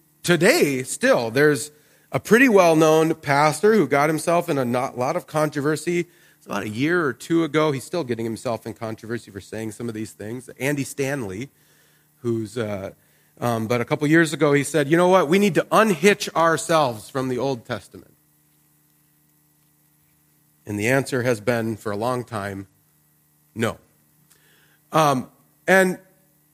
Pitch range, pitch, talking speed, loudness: 105-155 Hz, 130 Hz, 165 wpm, -21 LUFS